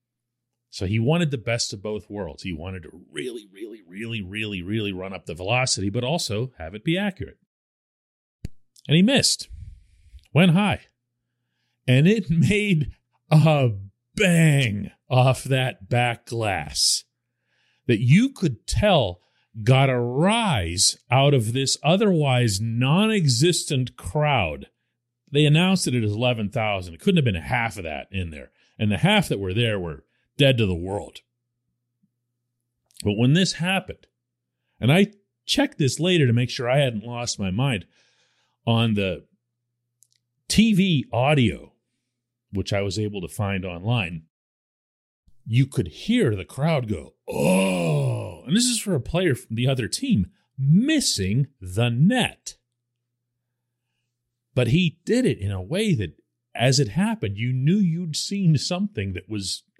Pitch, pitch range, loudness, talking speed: 120 Hz, 105-150 Hz, -22 LUFS, 145 wpm